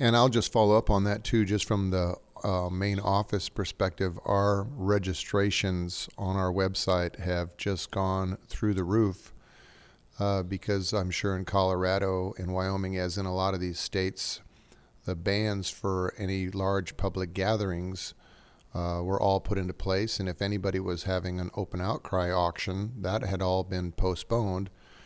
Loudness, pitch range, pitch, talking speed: -29 LUFS, 90-100 Hz, 95 Hz, 165 wpm